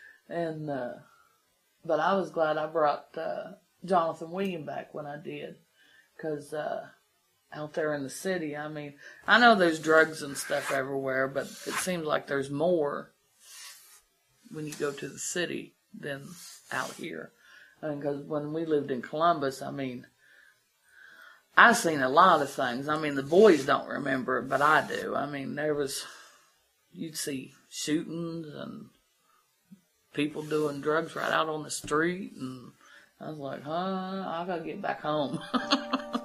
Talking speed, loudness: 165 wpm, -29 LUFS